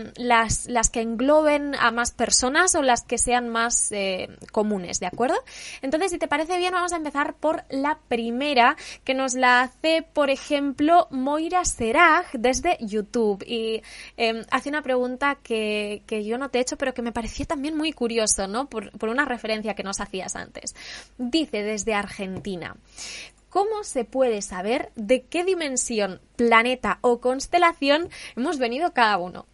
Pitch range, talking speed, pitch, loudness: 225-295 Hz, 165 wpm, 250 Hz, -23 LUFS